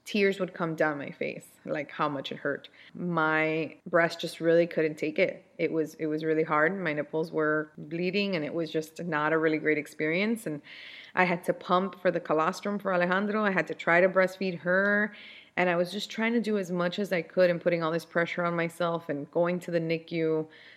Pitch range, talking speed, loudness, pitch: 160-185 Hz, 225 wpm, -28 LUFS, 170 Hz